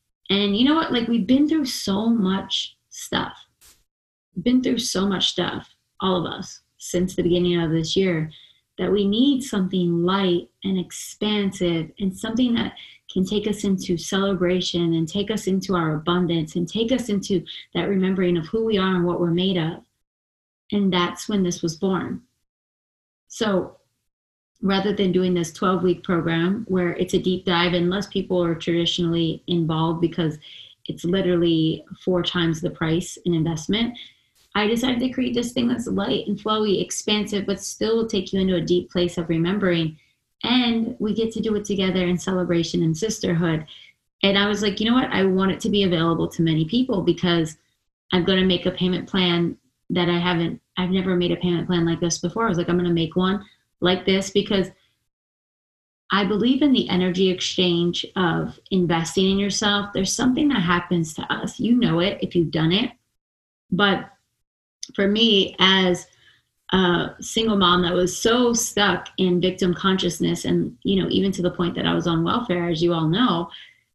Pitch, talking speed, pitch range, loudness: 185 Hz, 185 wpm, 175-205 Hz, -22 LUFS